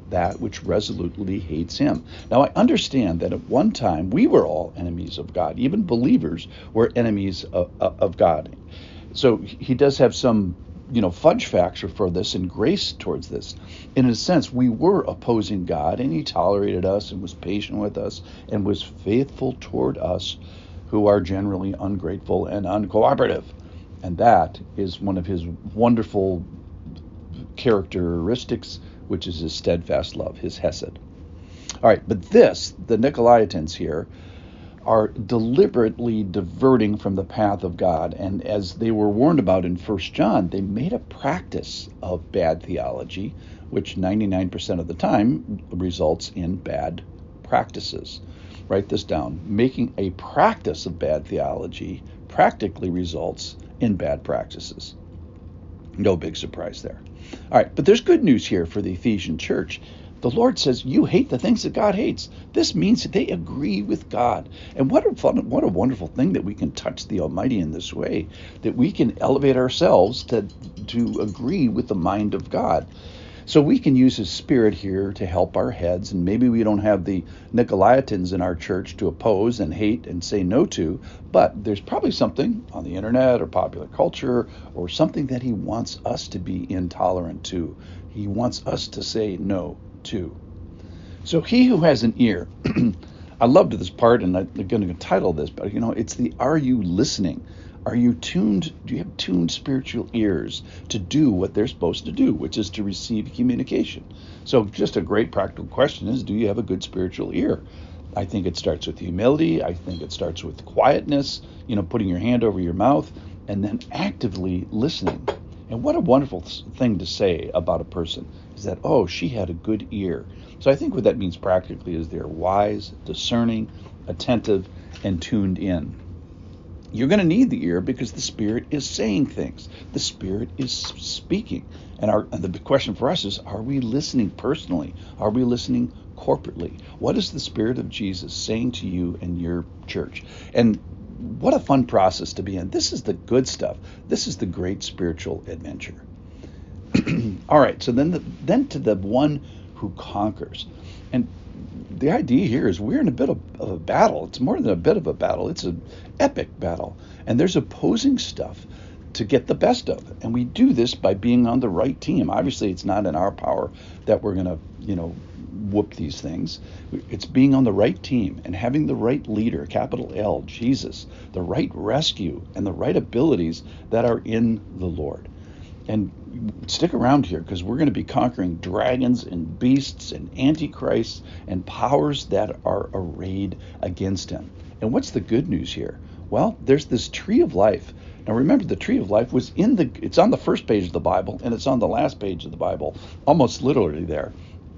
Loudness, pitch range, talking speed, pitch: -22 LUFS, 85-115 Hz, 180 wpm, 95 Hz